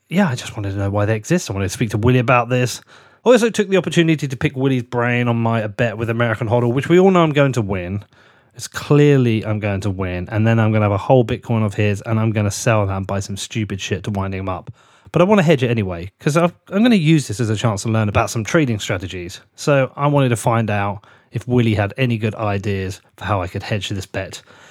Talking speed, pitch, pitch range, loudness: 275 wpm, 115 Hz, 105-130 Hz, -18 LUFS